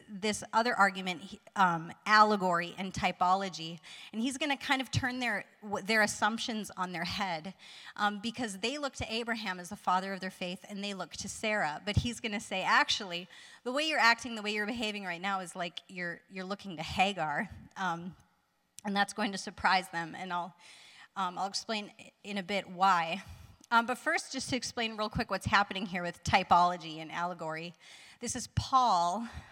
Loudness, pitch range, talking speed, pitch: -32 LUFS, 180-225 Hz, 185 wpm, 200 Hz